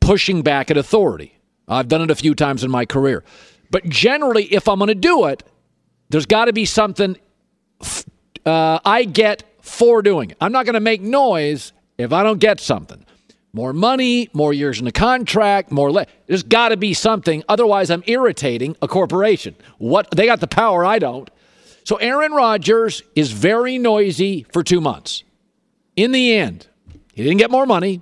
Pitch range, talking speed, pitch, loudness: 155-225 Hz, 185 wpm, 200 Hz, -16 LUFS